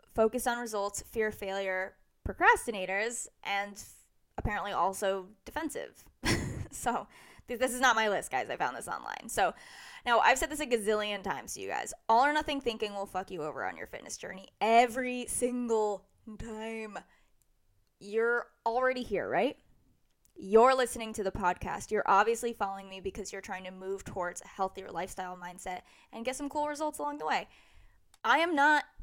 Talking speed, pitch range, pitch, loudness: 175 wpm, 195-245 Hz, 215 Hz, -31 LUFS